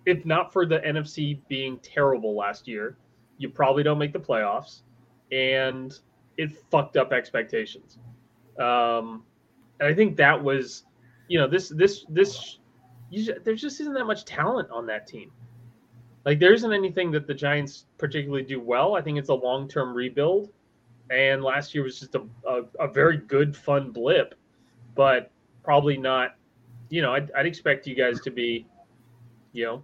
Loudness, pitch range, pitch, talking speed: -25 LUFS, 120-150 Hz, 135 Hz, 170 wpm